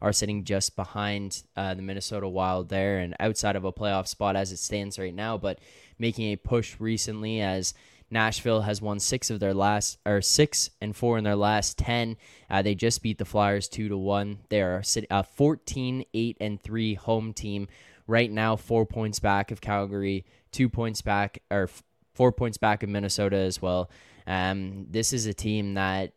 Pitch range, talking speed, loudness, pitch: 95-110 Hz, 195 wpm, -27 LUFS, 105 Hz